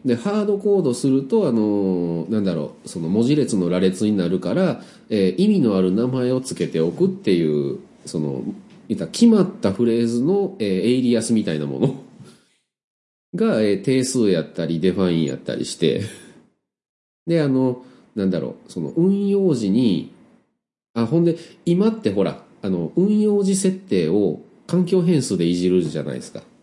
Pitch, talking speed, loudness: 125 Hz, 315 characters per minute, -20 LUFS